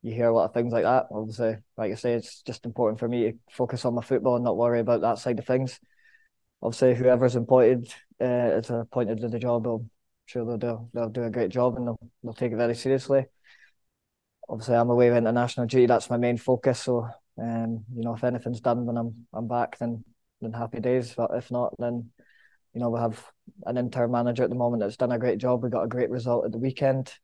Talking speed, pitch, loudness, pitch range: 240 wpm, 120 Hz, -26 LUFS, 115-125 Hz